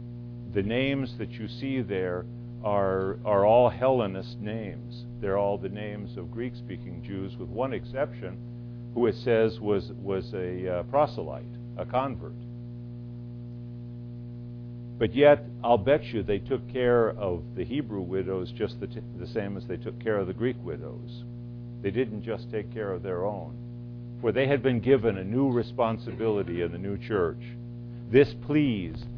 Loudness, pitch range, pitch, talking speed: -28 LUFS, 110-120 Hz, 120 Hz, 160 wpm